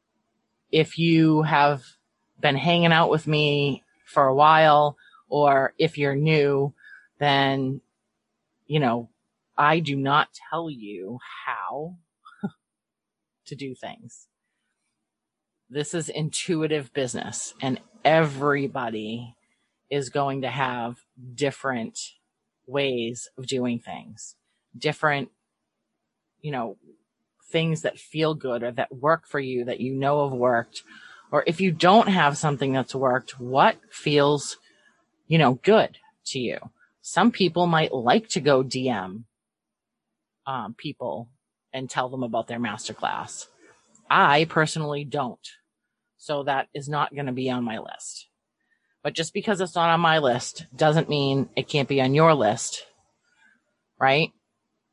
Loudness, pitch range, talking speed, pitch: -23 LUFS, 130-160 Hz, 130 wpm, 145 Hz